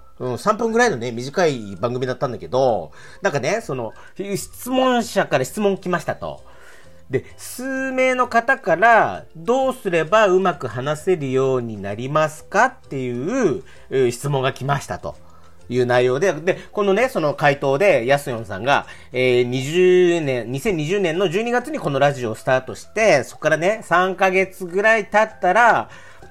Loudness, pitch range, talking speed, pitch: -19 LUFS, 125-200 Hz, 290 characters per minute, 155 Hz